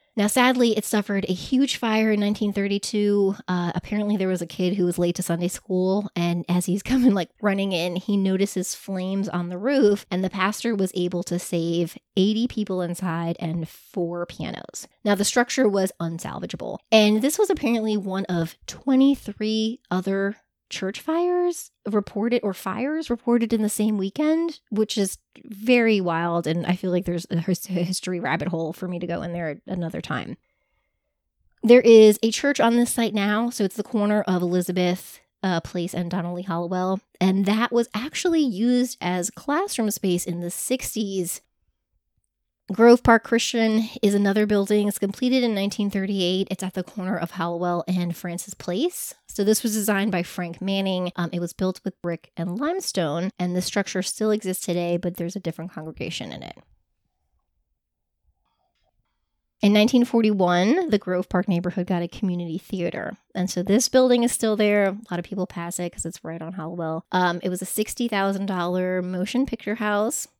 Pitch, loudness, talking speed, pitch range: 195 Hz, -23 LUFS, 175 wpm, 180-220 Hz